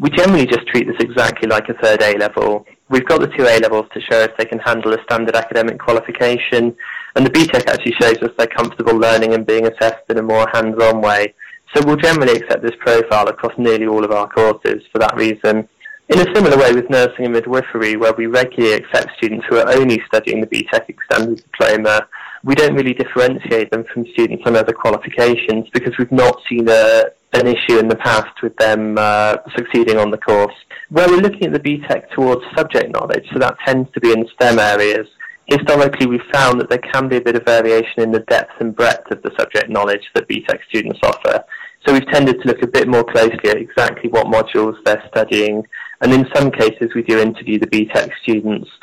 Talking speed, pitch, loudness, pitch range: 215 wpm, 115 Hz, -14 LUFS, 110-125 Hz